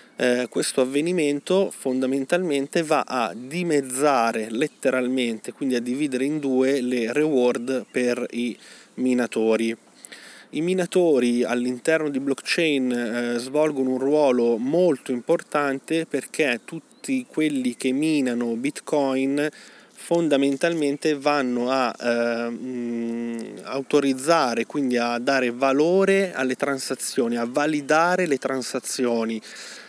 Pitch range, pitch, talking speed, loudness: 125-155 Hz, 135 Hz, 100 wpm, -23 LUFS